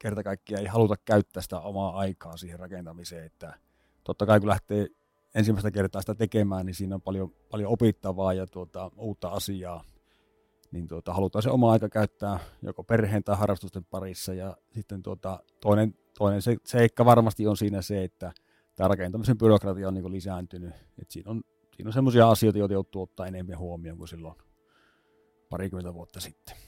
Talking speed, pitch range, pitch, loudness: 165 wpm, 90-110 Hz, 95 Hz, -27 LUFS